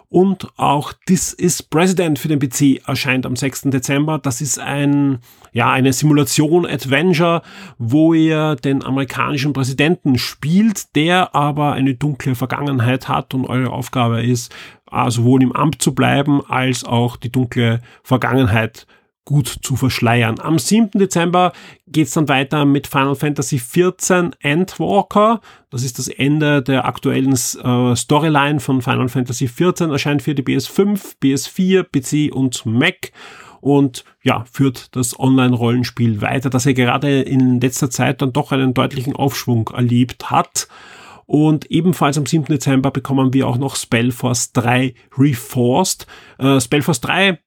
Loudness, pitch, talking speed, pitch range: -16 LUFS, 135 Hz, 150 wpm, 130-150 Hz